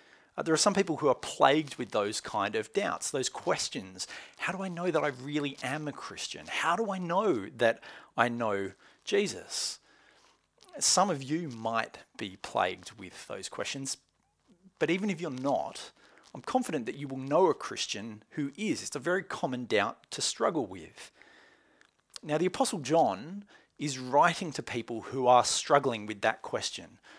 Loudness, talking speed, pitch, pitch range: -31 LUFS, 170 wpm, 150 Hz, 125-180 Hz